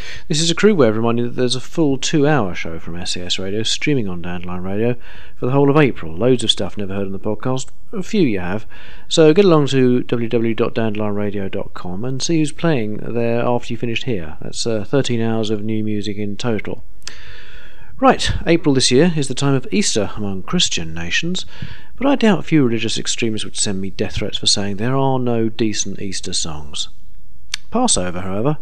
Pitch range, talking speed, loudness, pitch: 100-135 Hz, 200 wpm, -18 LUFS, 115 Hz